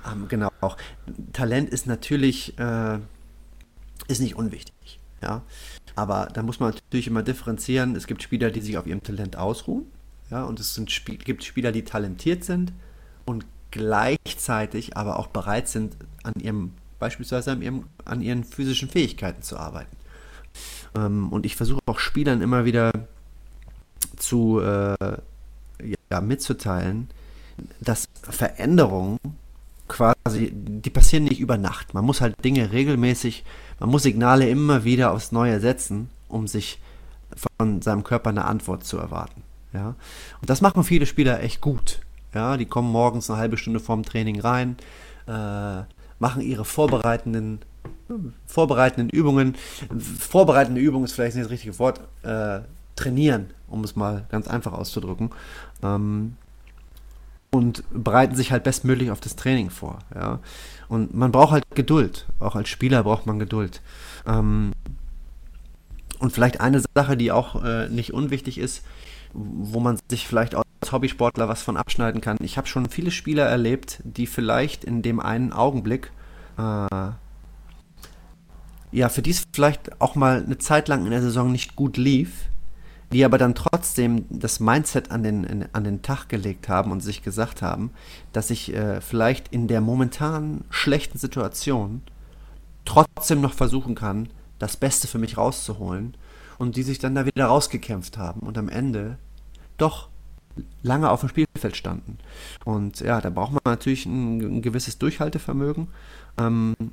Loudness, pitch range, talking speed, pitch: -23 LUFS, 105-130 Hz, 150 wpm, 115 Hz